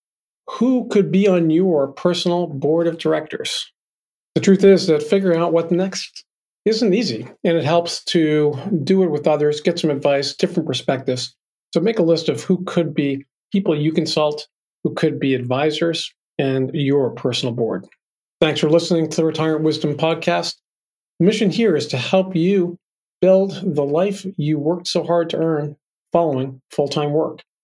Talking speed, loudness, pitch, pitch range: 170 wpm, -19 LUFS, 165 Hz, 150-180 Hz